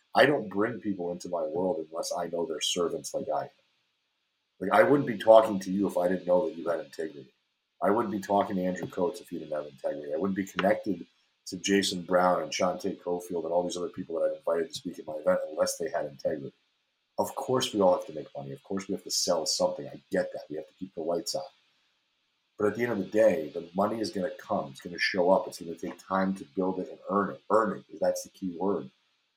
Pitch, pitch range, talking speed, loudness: 95 Hz, 90-110 Hz, 265 wpm, -29 LUFS